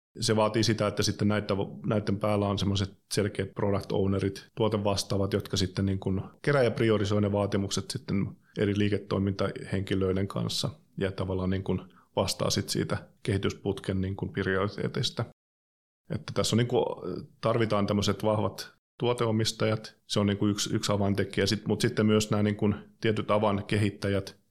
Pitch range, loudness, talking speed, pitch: 95-110 Hz, -29 LUFS, 140 wpm, 100 Hz